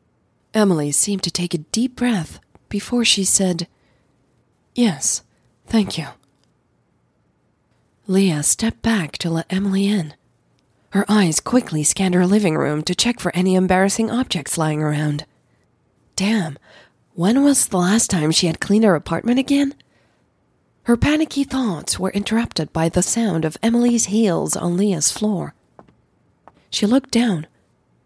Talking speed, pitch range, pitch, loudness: 135 wpm, 170-225 Hz, 195 Hz, -19 LUFS